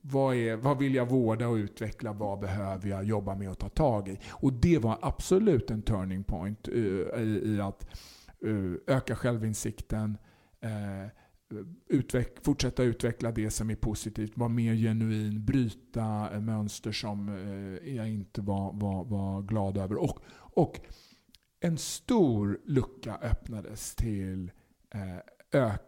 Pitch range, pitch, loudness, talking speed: 100-120 Hz, 110 Hz, -31 LUFS, 145 wpm